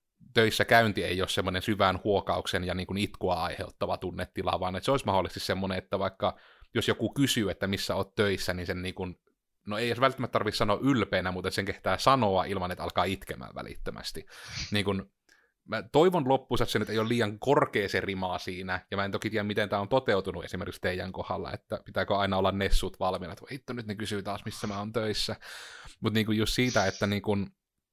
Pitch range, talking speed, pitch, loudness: 95-110 Hz, 210 wpm, 100 Hz, -29 LUFS